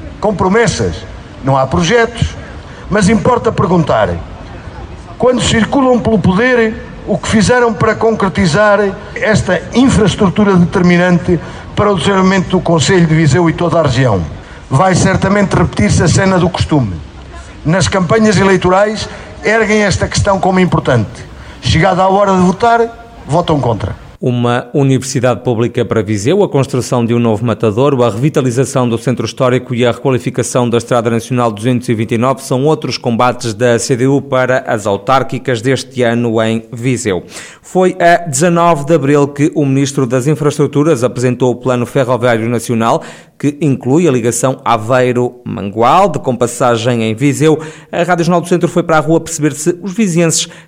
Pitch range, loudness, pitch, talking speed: 120-180 Hz, -12 LUFS, 140 Hz, 150 wpm